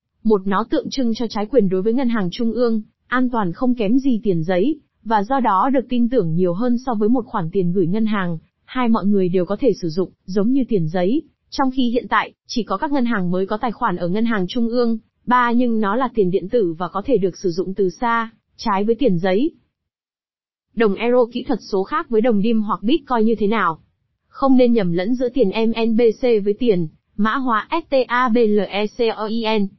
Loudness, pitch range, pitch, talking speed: -19 LUFS, 195-245 Hz, 225 Hz, 225 wpm